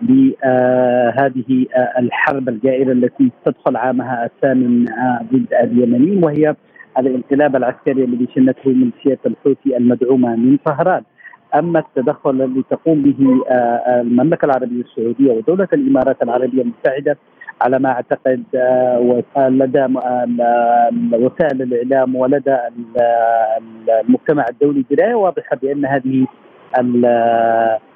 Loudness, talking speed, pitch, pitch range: -15 LUFS, 115 wpm, 130 Hz, 120-135 Hz